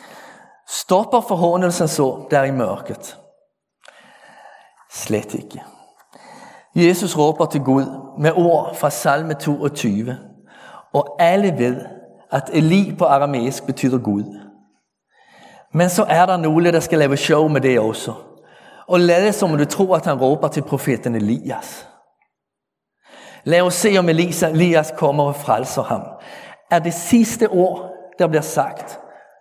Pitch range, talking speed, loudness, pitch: 140-180 Hz, 135 wpm, -17 LUFS, 160 Hz